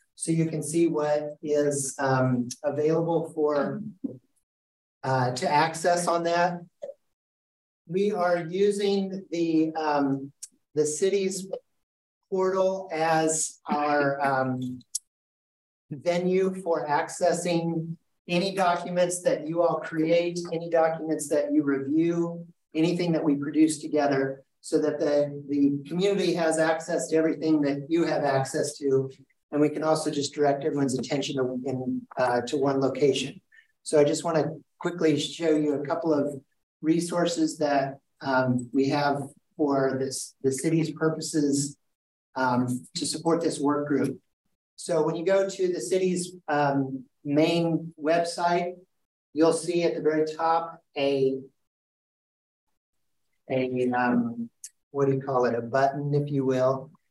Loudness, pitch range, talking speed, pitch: -26 LUFS, 140-170 Hz, 135 wpm, 155 Hz